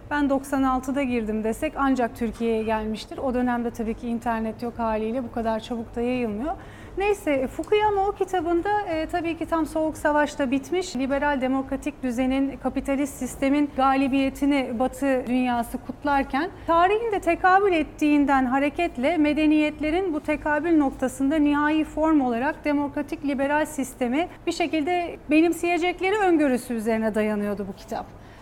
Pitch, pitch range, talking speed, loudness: 280 Hz, 250-315 Hz, 130 wpm, -24 LUFS